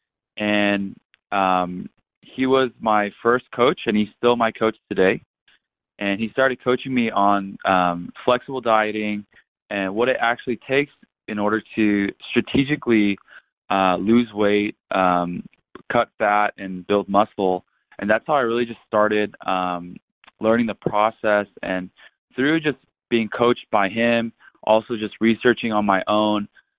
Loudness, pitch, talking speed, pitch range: -21 LUFS, 105 Hz, 145 wpm, 100-120 Hz